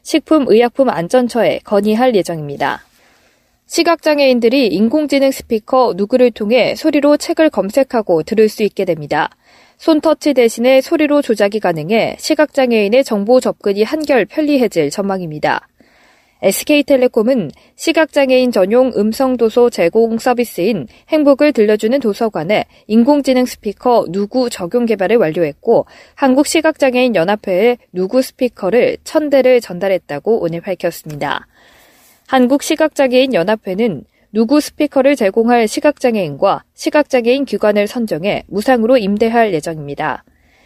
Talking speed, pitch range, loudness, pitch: 330 characters per minute, 205-275 Hz, -14 LUFS, 245 Hz